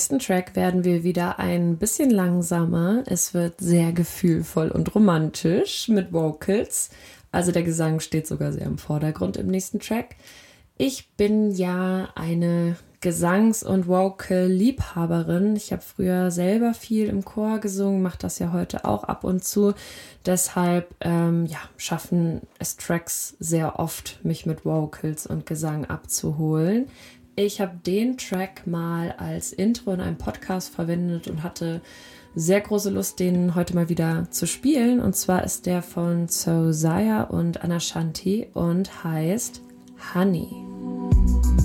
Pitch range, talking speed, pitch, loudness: 165-195 Hz, 140 wpm, 175 Hz, -24 LUFS